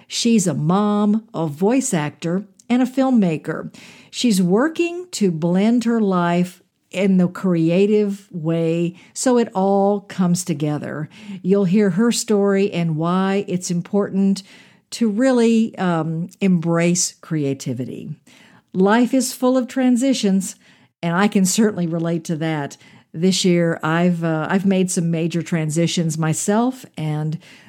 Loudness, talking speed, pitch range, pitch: -19 LUFS, 130 wpm, 170-210 Hz, 190 Hz